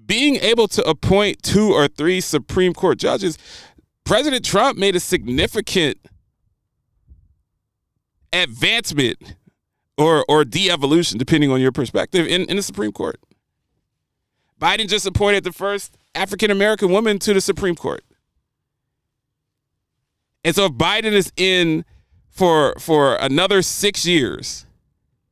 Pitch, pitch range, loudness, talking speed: 180 Hz, 145-200 Hz, -17 LUFS, 125 wpm